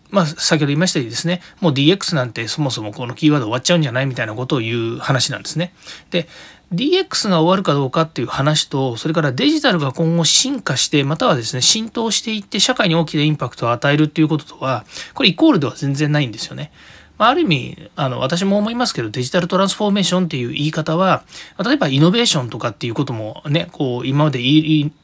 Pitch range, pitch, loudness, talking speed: 135-175 Hz, 155 Hz, -17 LUFS, 510 characters per minute